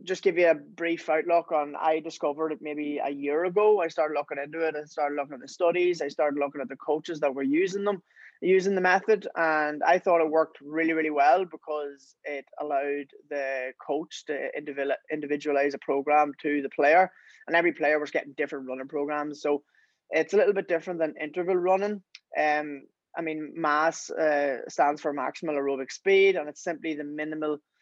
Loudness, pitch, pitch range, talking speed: -27 LUFS, 155 Hz, 145-170 Hz, 195 wpm